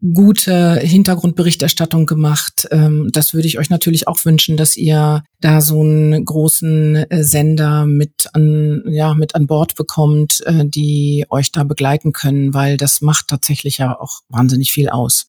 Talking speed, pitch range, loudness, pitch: 150 wpm, 145-160 Hz, -13 LUFS, 155 Hz